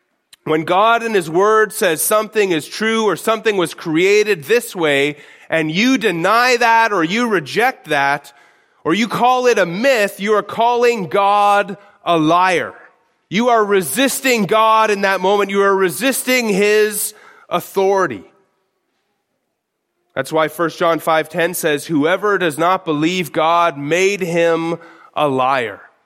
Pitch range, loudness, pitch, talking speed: 170-220 Hz, -15 LUFS, 200 Hz, 145 wpm